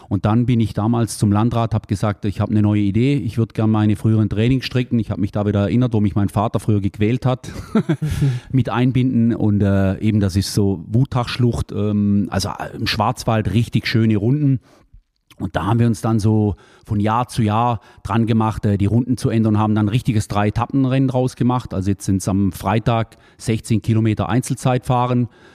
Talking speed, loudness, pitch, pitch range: 195 wpm, -19 LUFS, 110 Hz, 105-125 Hz